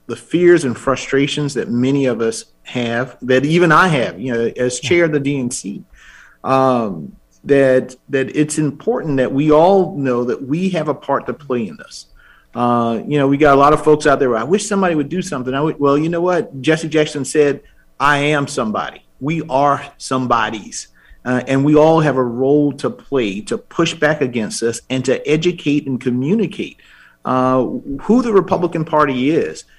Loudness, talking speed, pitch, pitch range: -16 LUFS, 195 wpm, 140 Hz, 130-155 Hz